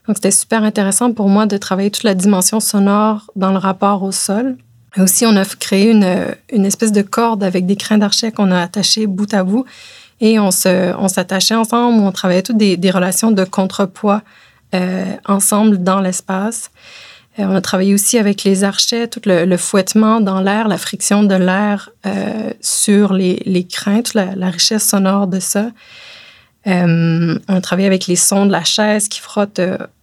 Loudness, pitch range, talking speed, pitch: -14 LUFS, 190-215 Hz, 195 wpm, 200 Hz